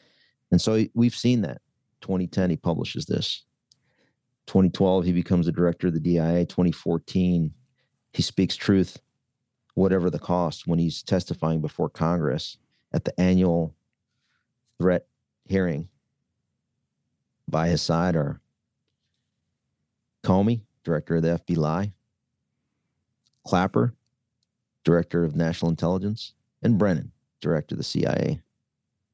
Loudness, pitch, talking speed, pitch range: -25 LUFS, 90 Hz, 110 wpm, 85-110 Hz